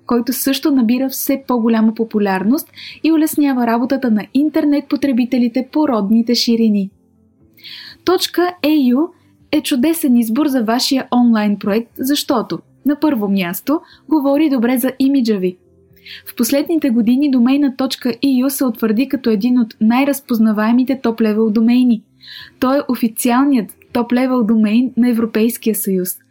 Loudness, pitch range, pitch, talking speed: -15 LUFS, 230-280 Hz, 250 Hz, 125 wpm